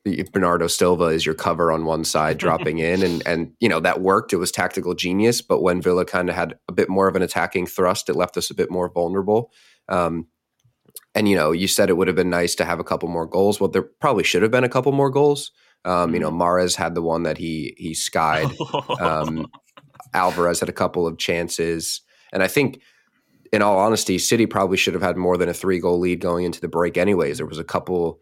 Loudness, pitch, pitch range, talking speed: -20 LUFS, 90 Hz, 85-95 Hz, 235 wpm